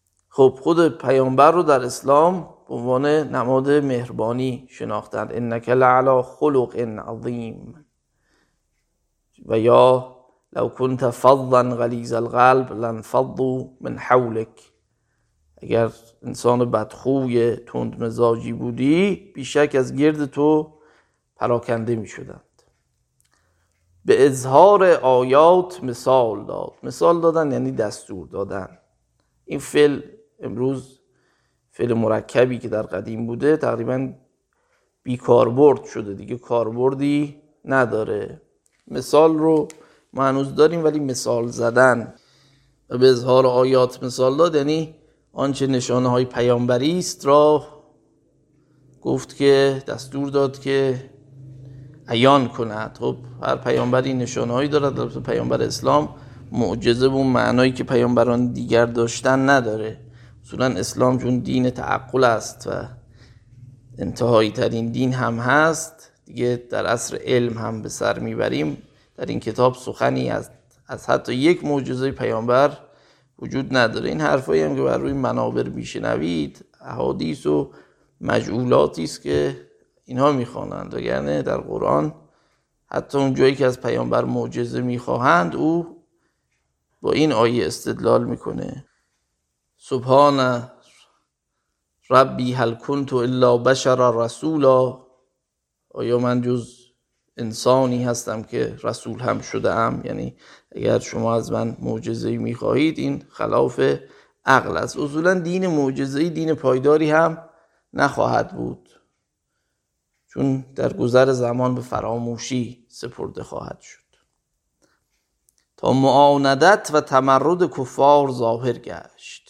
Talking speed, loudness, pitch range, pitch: 110 wpm, -20 LUFS, 115-140 Hz, 125 Hz